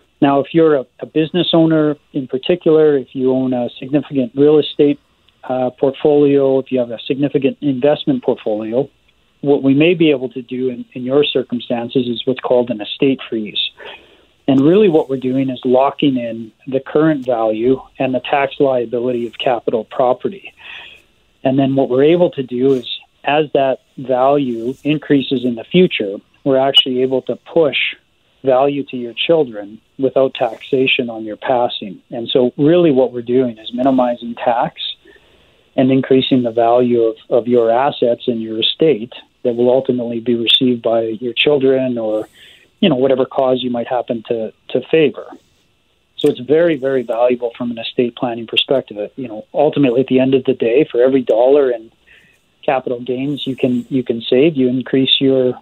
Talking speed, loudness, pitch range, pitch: 175 wpm, -15 LUFS, 120-140 Hz, 130 Hz